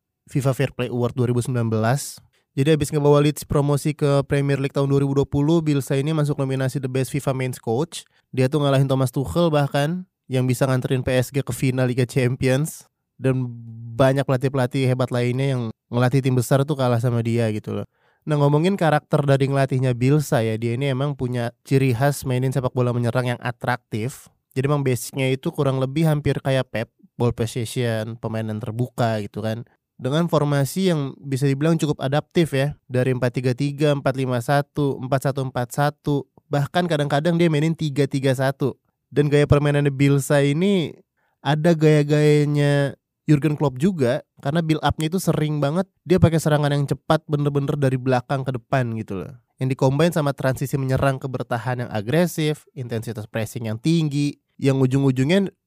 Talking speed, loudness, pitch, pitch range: 160 wpm, -21 LUFS, 140 Hz, 125-150 Hz